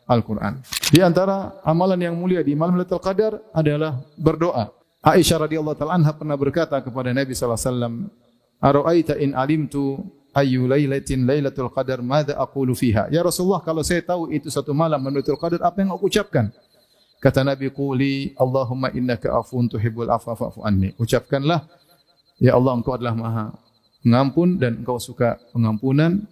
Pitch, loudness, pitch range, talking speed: 140 Hz, -21 LUFS, 125-165 Hz, 150 wpm